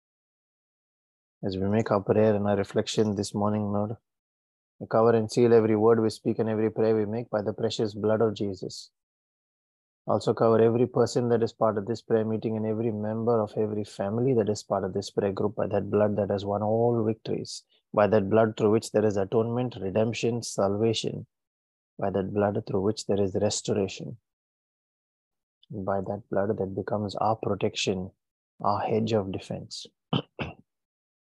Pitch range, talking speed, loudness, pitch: 100-115 Hz, 170 wpm, -27 LUFS, 110 Hz